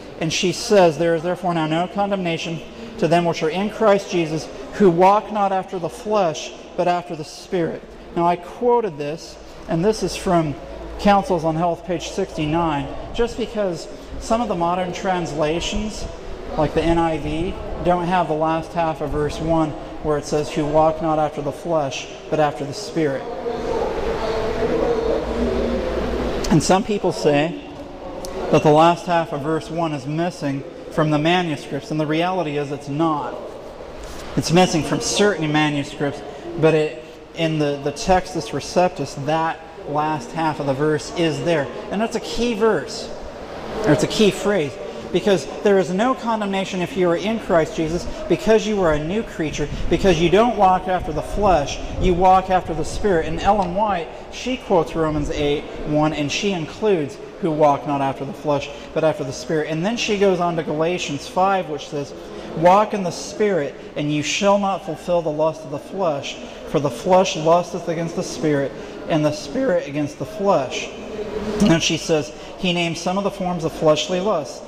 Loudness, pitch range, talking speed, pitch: -20 LUFS, 155-190 Hz, 180 wpm, 170 Hz